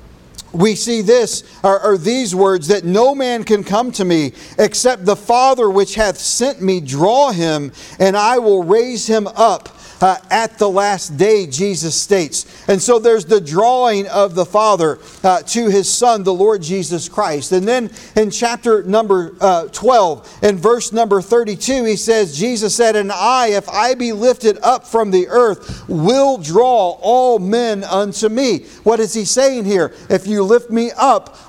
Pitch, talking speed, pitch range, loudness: 210 Hz, 175 wpm, 190-235 Hz, -14 LUFS